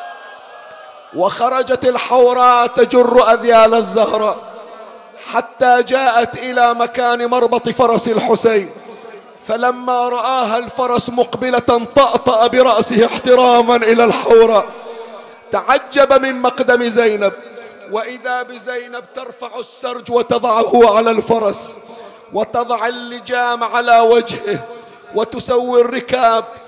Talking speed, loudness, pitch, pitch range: 85 wpm, -13 LUFS, 235 Hz, 230-245 Hz